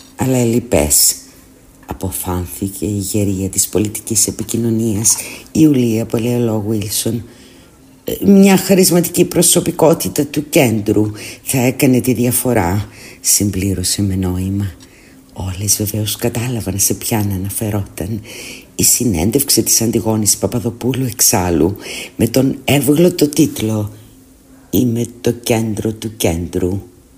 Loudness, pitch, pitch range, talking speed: -14 LUFS, 110 Hz, 100-125 Hz, 100 wpm